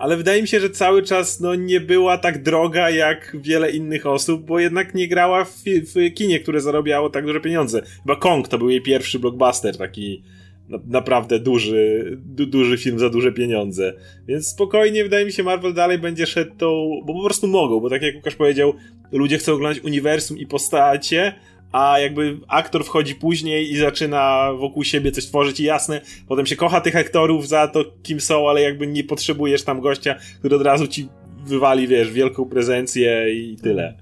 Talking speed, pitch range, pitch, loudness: 190 wpm, 130-165 Hz, 145 Hz, -19 LUFS